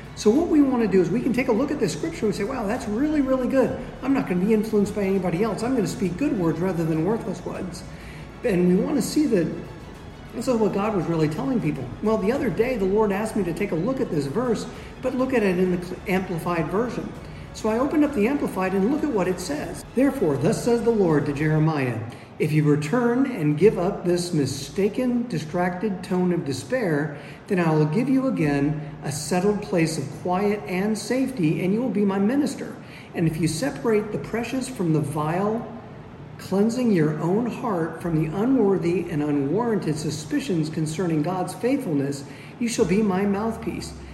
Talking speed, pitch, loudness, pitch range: 210 wpm, 195 Hz, -23 LUFS, 160-230 Hz